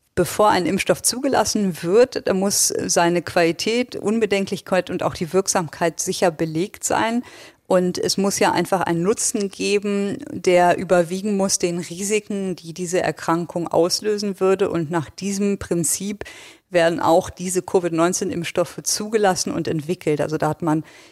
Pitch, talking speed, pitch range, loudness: 185 Hz, 140 wpm, 170-205 Hz, -20 LUFS